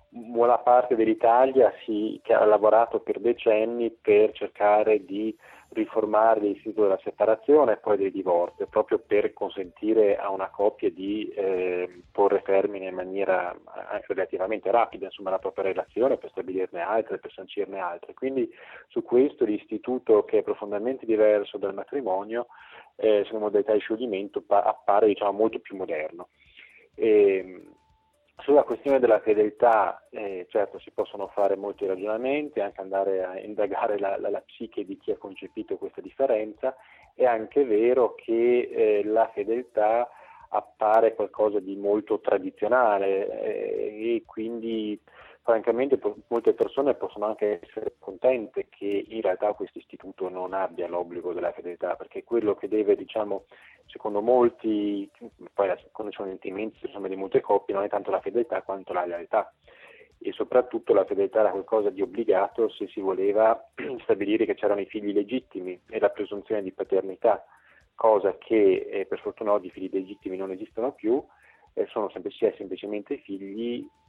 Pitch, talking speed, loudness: 120 Hz, 150 wpm, -26 LUFS